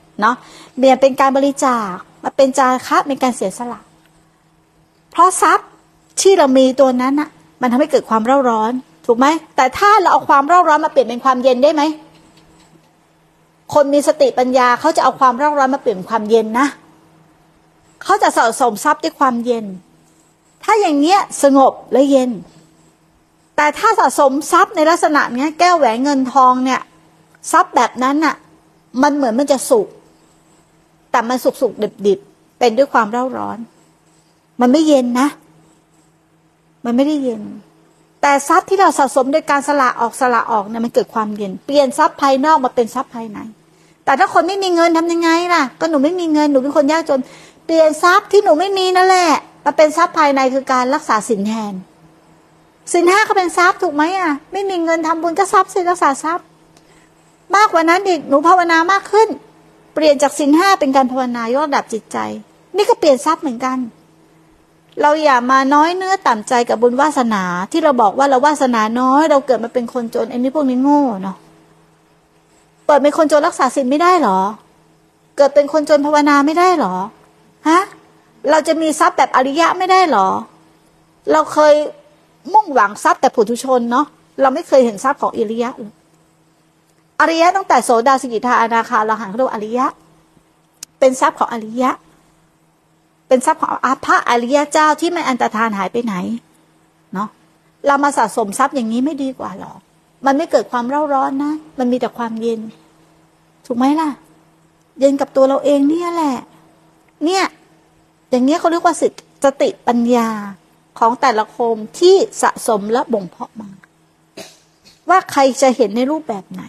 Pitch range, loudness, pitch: 245-315 Hz, -14 LUFS, 275 Hz